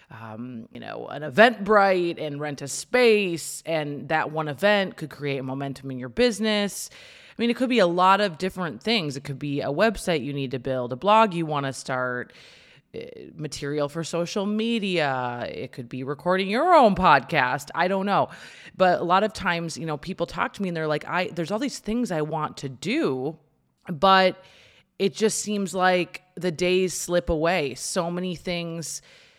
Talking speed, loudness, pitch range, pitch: 190 wpm, -24 LUFS, 145-200 Hz, 175 Hz